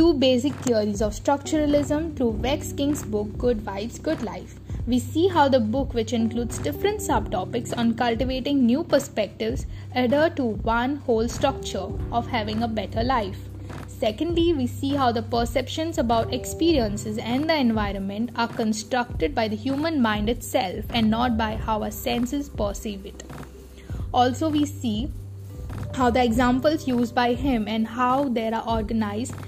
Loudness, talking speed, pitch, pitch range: -24 LUFS, 155 wpm, 245 Hz, 220-275 Hz